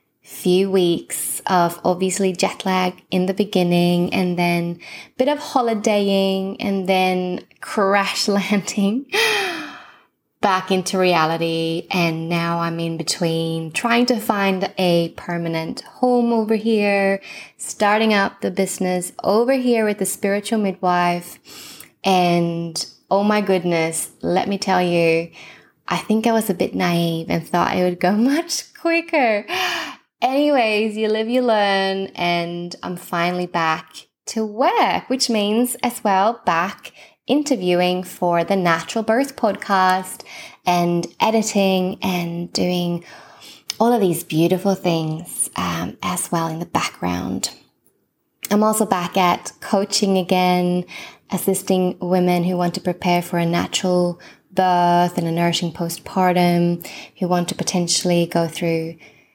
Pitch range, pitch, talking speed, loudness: 175-210 Hz, 185 Hz, 130 wpm, -19 LUFS